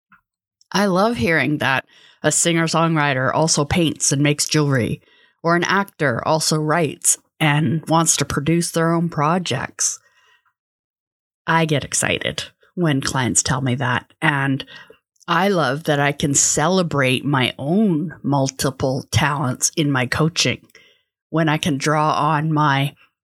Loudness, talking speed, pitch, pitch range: -18 LUFS, 135 wpm, 150 Hz, 140-165 Hz